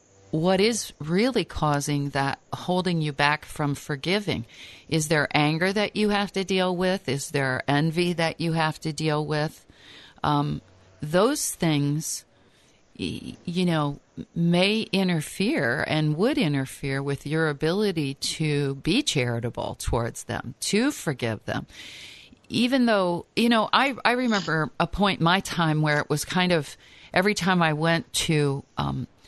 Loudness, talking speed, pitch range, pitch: -25 LUFS, 150 wpm, 145-185 Hz, 160 Hz